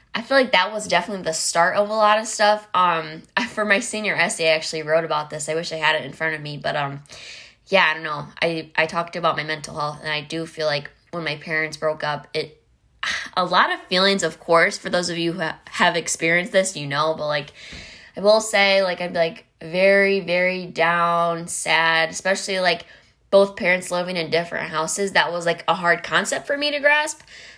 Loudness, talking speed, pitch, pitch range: -20 LUFS, 220 wpm, 170 Hz, 155-195 Hz